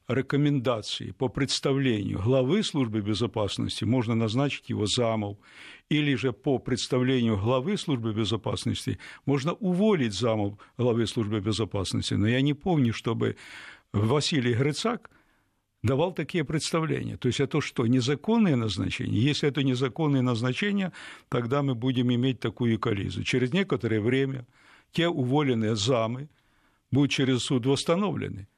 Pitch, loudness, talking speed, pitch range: 130 Hz, -27 LUFS, 125 wpm, 115-140 Hz